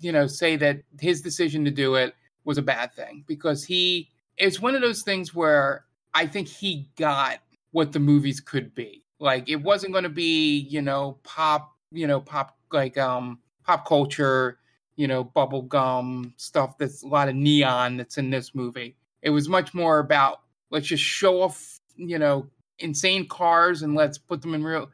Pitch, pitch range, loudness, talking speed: 145 Hz, 135-165 Hz, -24 LUFS, 190 wpm